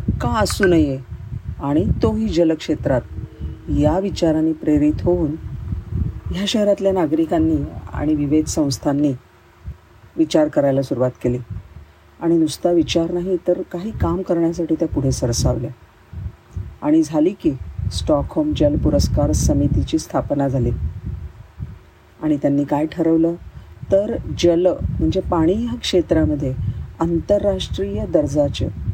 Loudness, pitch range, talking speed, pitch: -19 LUFS, 105-170 Hz, 110 wpm, 145 Hz